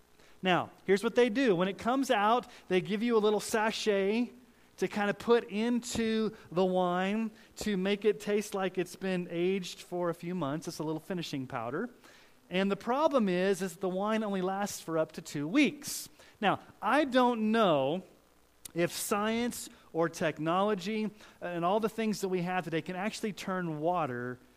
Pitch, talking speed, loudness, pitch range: 195 Hz, 180 wpm, -31 LUFS, 175-220 Hz